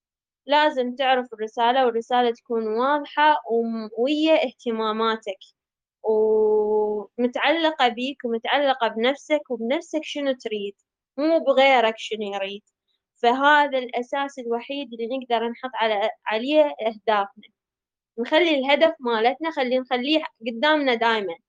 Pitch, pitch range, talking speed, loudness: 245 Hz, 225-280 Hz, 100 wpm, -22 LUFS